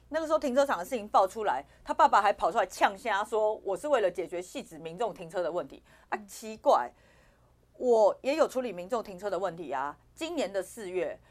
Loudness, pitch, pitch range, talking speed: -29 LUFS, 220 Hz, 190-280 Hz, 315 characters per minute